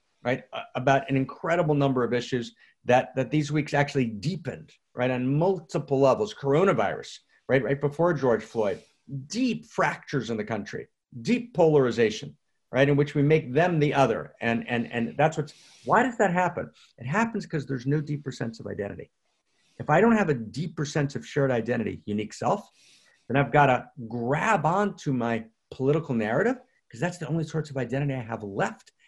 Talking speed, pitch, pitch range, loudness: 180 wpm, 140 Hz, 125-165 Hz, -26 LUFS